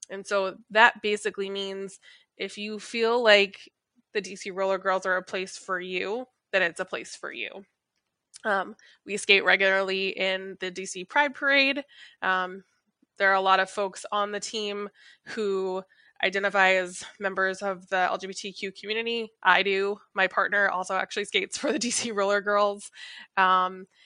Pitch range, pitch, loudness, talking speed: 190-215 Hz, 195 Hz, -26 LUFS, 160 wpm